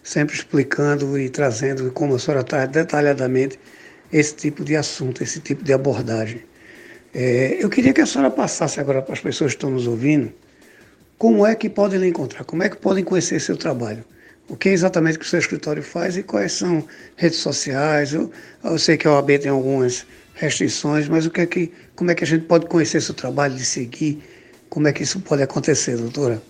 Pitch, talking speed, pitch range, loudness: 150 Hz, 205 wpm, 135-170 Hz, -20 LUFS